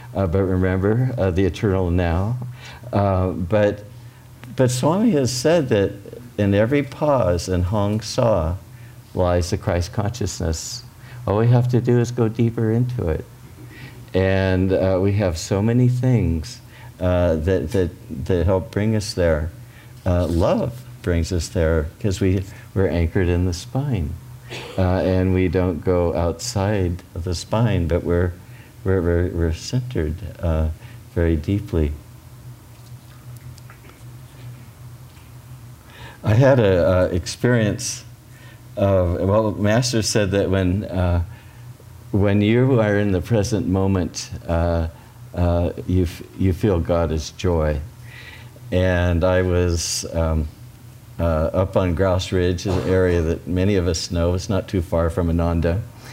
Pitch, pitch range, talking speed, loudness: 100 Hz, 90-120 Hz, 135 wpm, -20 LUFS